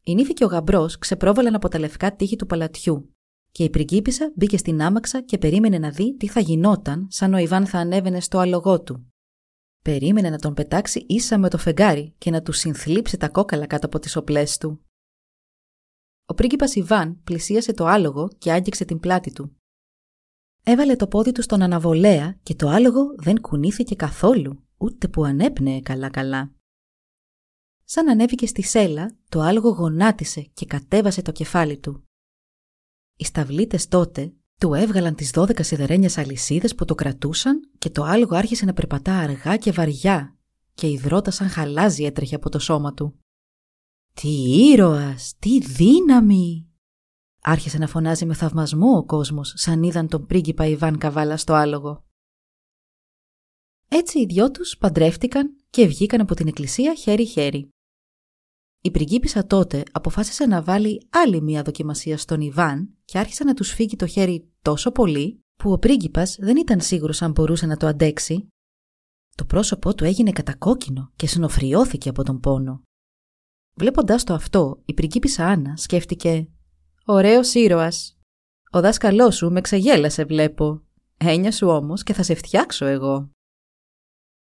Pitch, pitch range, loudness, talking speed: 165 Hz, 150-205 Hz, -20 LUFS, 155 wpm